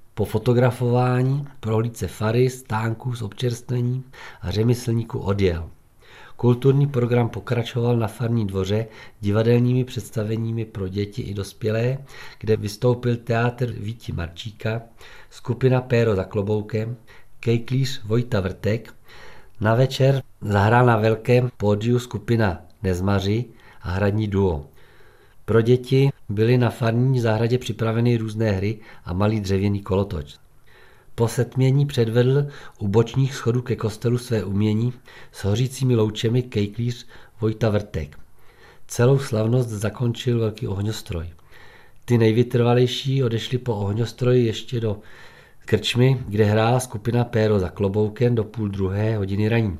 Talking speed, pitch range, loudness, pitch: 120 wpm, 105-125 Hz, -22 LUFS, 115 Hz